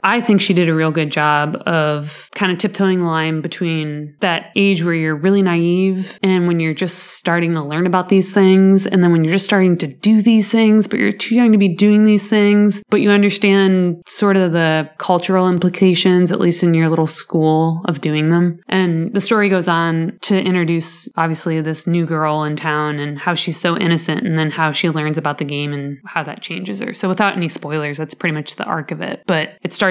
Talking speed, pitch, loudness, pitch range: 225 wpm, 175 Hz, -16 LUFS, 160-195 Hz